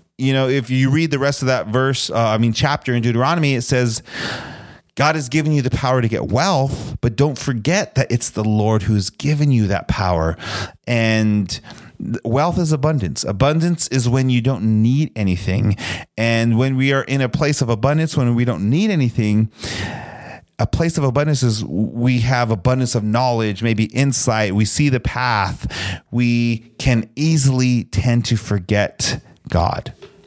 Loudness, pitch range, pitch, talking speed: -18 LUFS, 110-135 Hz, 125 Hz, 170 wpm